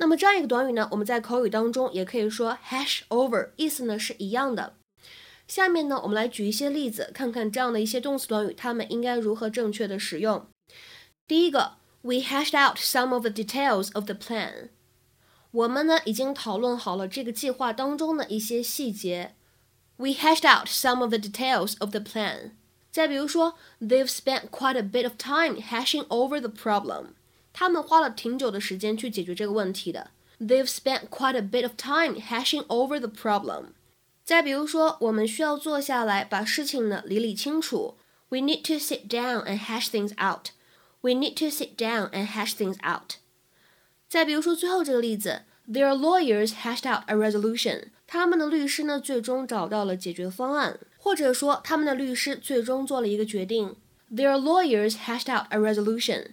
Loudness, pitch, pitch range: -26 LUFS, 245 Hz, 215-280 Hz